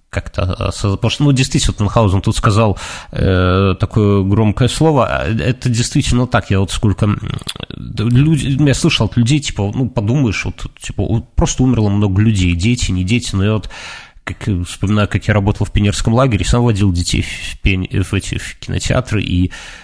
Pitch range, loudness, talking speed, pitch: 100-120 Hz, -15 LUFS, 170 wpm, 105 Hz